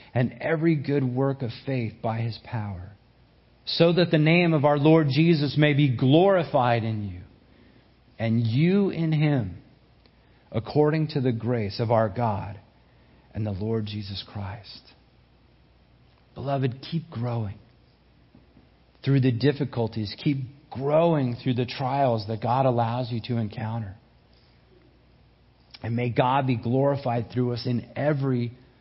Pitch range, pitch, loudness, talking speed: 115-145 Hz, 120 Hz, -25 LUFS, 135 wpm